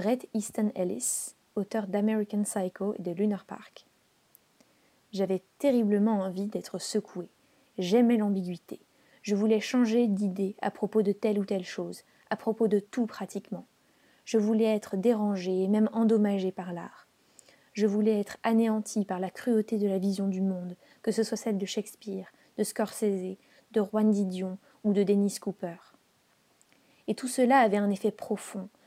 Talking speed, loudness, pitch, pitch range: 160 wpm, -29 LUFS, 210 Hz, 195-220 Hz